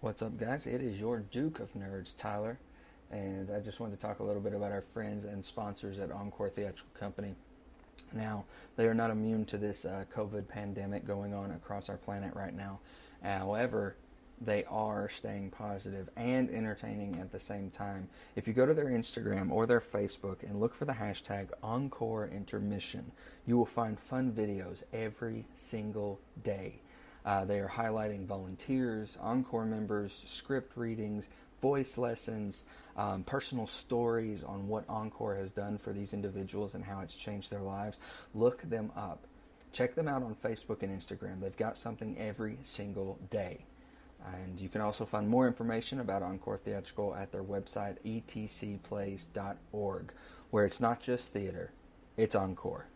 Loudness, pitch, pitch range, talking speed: -37 LUFS, 105 Hz, 100-115 Hz, 165 wpm